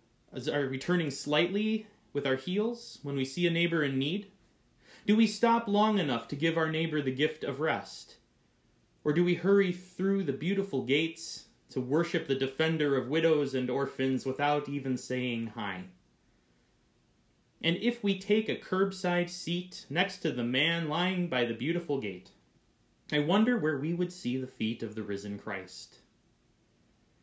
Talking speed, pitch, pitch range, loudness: 165 wpm, 155 Hz, 130-180 Hz, -31 LUFS